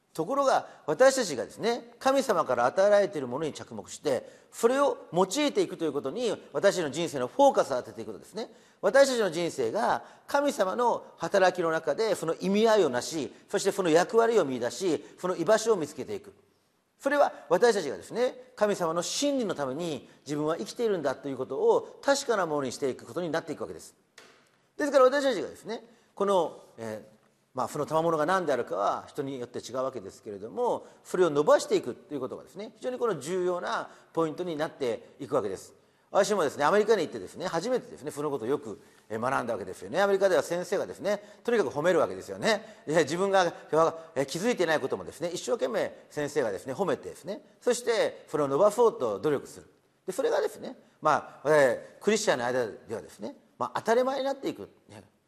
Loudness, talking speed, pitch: -28 LUFS, 430 characters per minute, 200 Hz